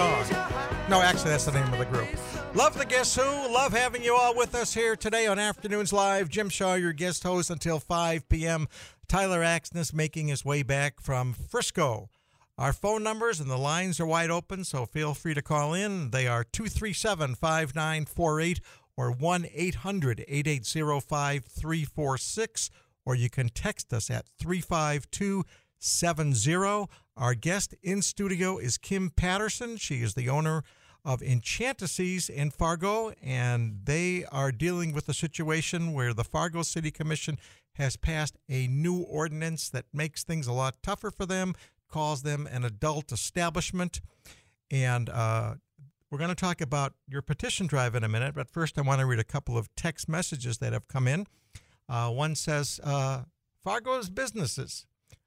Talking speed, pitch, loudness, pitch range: 160 wpm, 155 Hz, -29 LUFS, 135-180 Hz